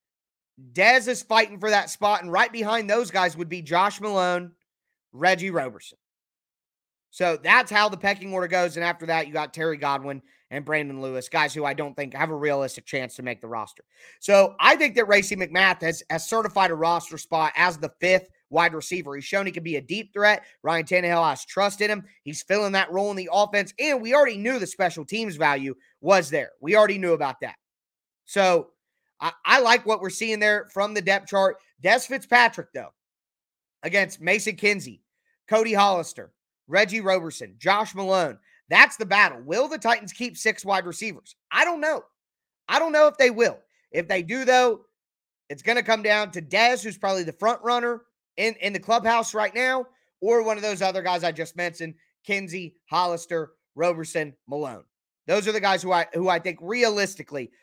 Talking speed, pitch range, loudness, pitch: 195 wpm, 165-220 Hz, -23 LUFS, 190 Hz